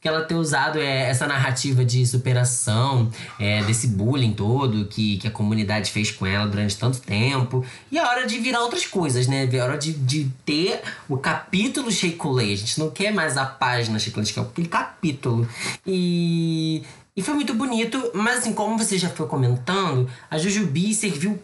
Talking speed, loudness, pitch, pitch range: 190 wpm, -22 LUFS, 135 Hz, 120-180 Hz